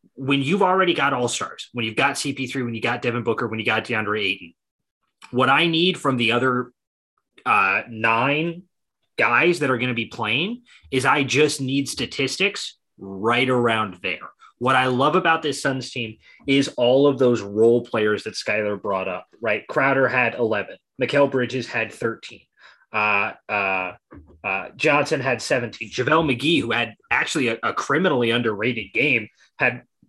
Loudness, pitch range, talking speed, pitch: -21 LUFS, 115-140 Hz, 170 wpm, 125 Hz